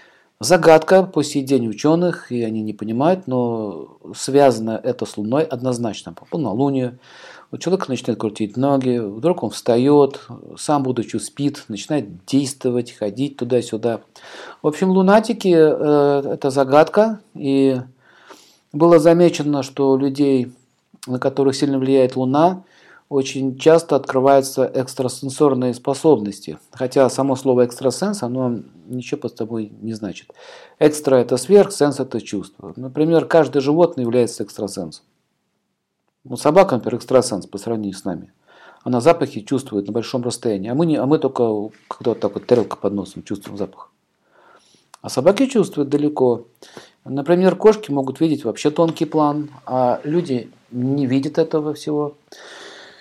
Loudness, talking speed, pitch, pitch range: -18 LUFS, 135 wpm, 135 Hz, 120-150 Hz